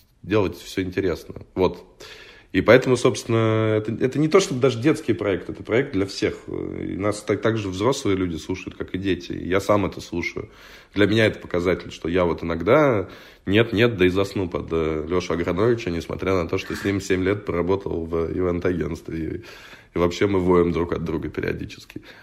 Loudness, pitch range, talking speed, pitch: -22 LUFS, 85-110 Hz, 195 wpm, 95 Hz